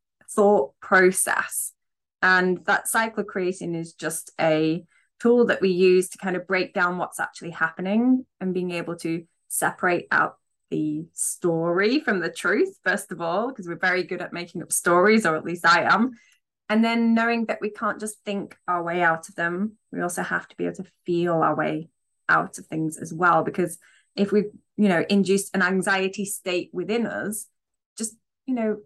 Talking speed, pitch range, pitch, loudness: 190 wpm, 170-210 Hz, 185 Hz, -23 LUFS